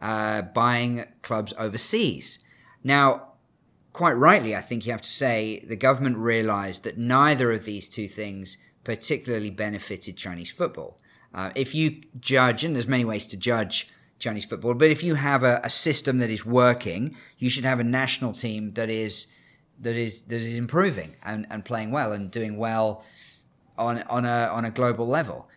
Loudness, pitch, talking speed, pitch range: -25 LUFS, 115 Hz, 175 wpm, 110-130 Hz